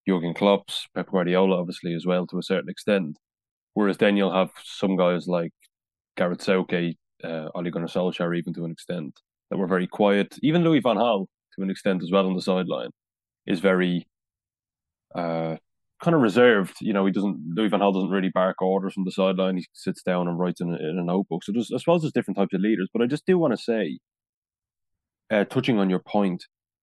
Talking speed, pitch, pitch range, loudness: 210 wpm, 95 Hz, 90-100 Hz, -24 LUFS